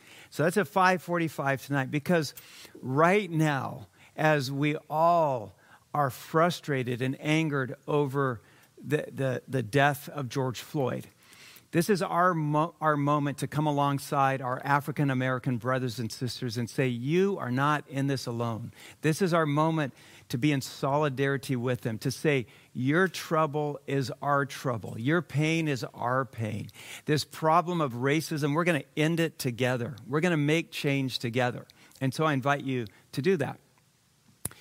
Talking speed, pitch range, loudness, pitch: 160 wpm, 130-155 Hz, -28 LUFS, 145 Hz